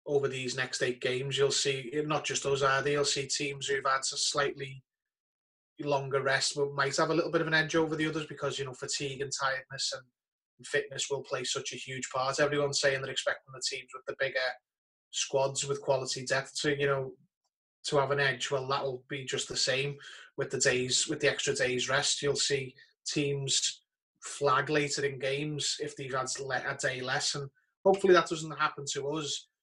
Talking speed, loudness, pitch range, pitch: 205 wpm, -30 LUFS, 135-145 Hz, 140 Hz